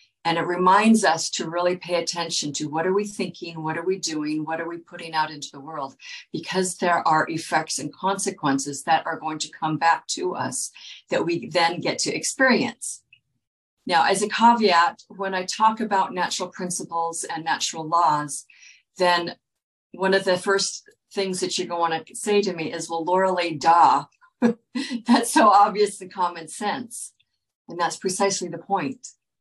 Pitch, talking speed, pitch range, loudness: 175 Hz, 180 wpm, 160-195 Hz, -23 LUFS